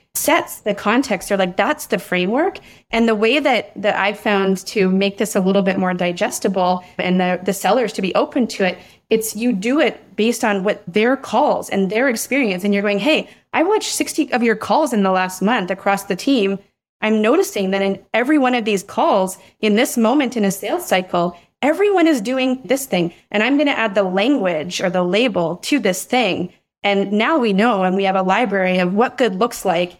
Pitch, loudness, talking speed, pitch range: 210 Hz, -18 LUFS, 220 wpm, 190-245 Hz